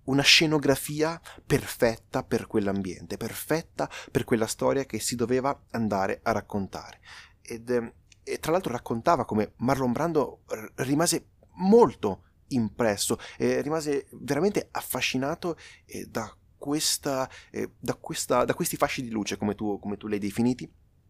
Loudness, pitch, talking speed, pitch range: -27 LUFS, 120 Hz, 140 wpm, 105-140 Hz